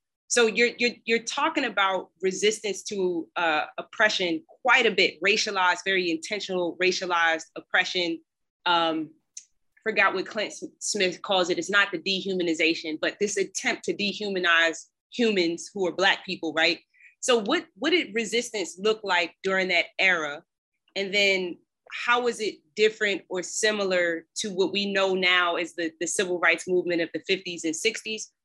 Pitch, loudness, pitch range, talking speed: 190 Hz, -25 LUFS, 170-215 Hz, 155 wpm